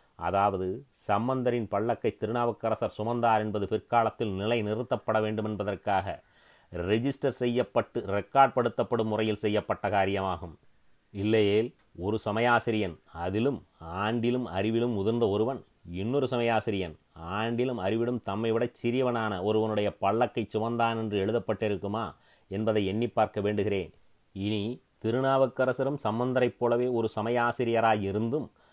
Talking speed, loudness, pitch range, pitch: 100 wpm, -29 LUFS, 105-120 Hz, 110 Hz